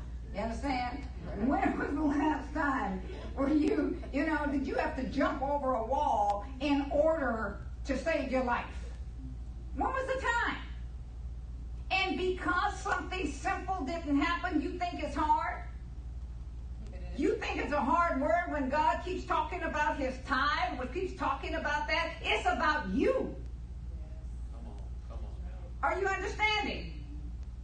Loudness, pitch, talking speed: -32 LUFS, 285 Hz, 135 wpm